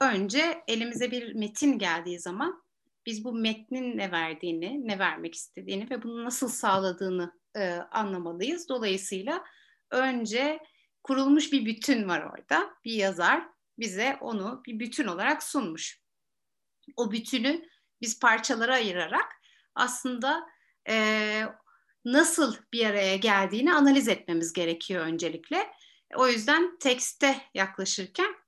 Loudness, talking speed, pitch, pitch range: -28 LUFS, 115 wpm, 235 Hz, 195-280 Hz